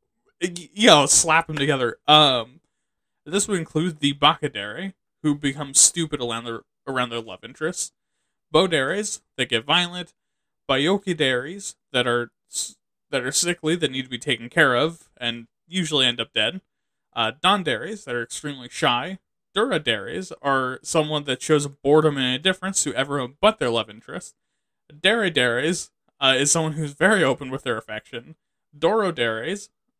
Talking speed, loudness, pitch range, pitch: 145 wpm, -21 LUFS, 125-170 Hz, 150 Hz